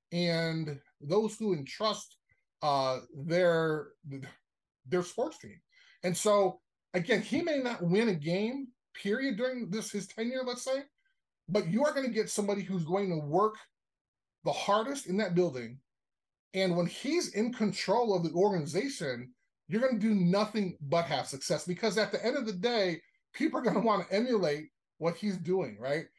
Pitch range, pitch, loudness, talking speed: 165-220 Hz, 195 Hz, -32 LUFS, 170 wpm